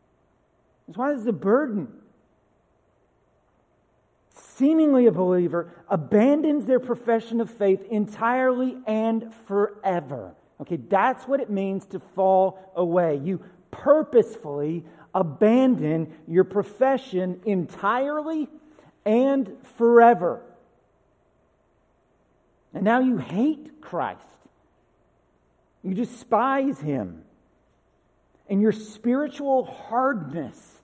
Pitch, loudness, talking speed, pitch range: 215 Hz, -23 LUFS, 85 wpm, 190-255 Hz